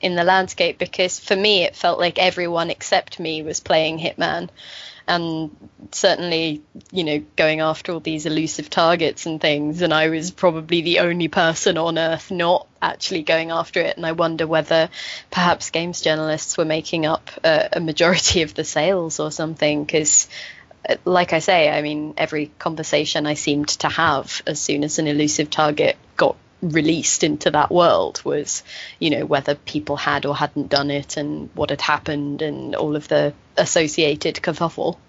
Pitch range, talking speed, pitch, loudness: 150-170 Hz, 175 wpm, 160 Hz, -20 LUFS